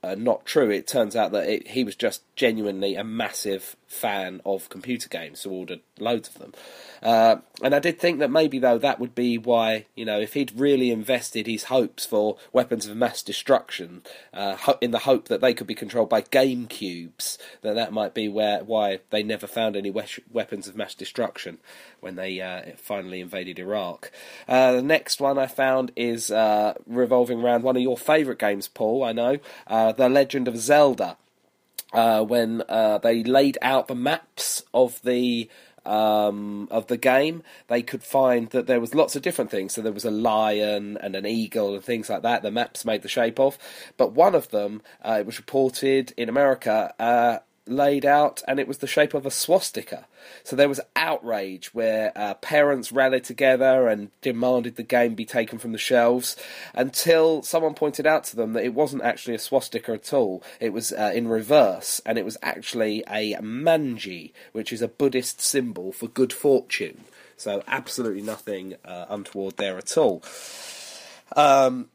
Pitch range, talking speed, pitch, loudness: 110-130 Hz, 190 wpm, 120 Hz, -23 LUFS